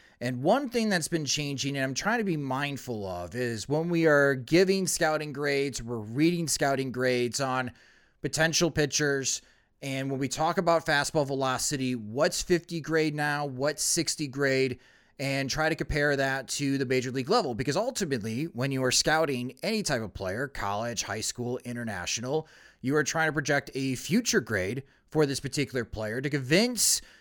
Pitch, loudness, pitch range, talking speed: 140 Hz, -28 LUFS, 130-155 Hz, 175 wpm